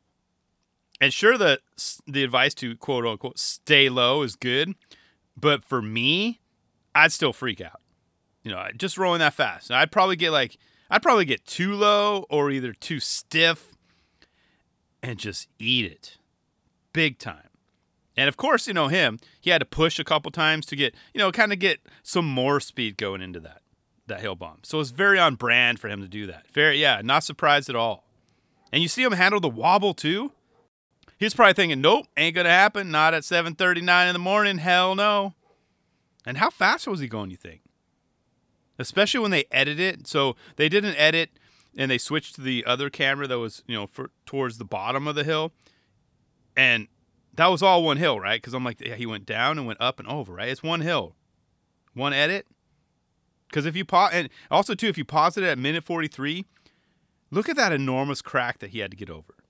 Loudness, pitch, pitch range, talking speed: -22 LUFS, 145 Hz, 125-175 Hz, 200 wpm